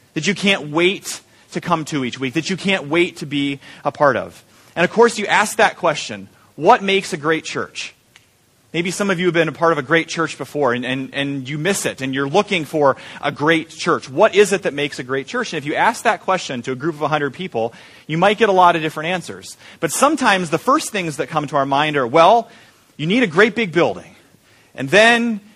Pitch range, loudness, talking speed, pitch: 145-195 Hz, -17 LUFS, 245 wpm, 165 Hz